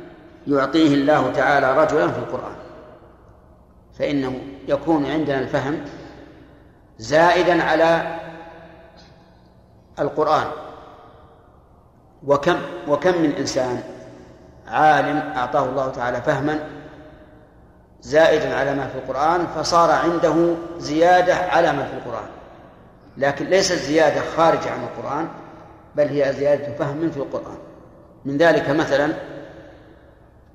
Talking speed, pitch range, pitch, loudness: 95 wpm, 135-165 Hz, 150 Hz, -19 LUFS